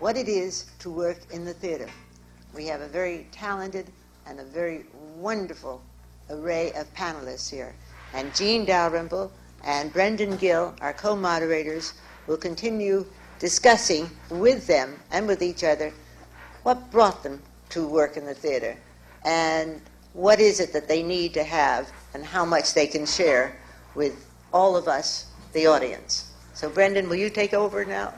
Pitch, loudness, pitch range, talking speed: 165 Hz, -24 LUFS, 145-190 Hz, 160 wpm